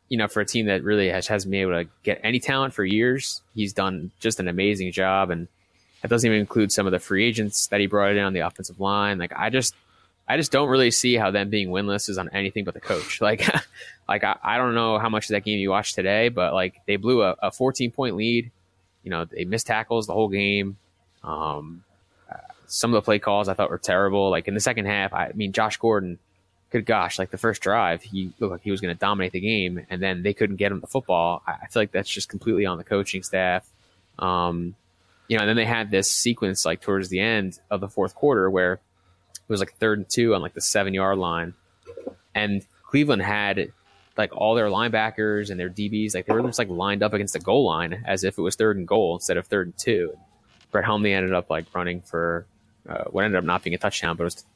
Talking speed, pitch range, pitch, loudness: 245 wpm, 95-110 Hz, 100 Hz, -23 LUFS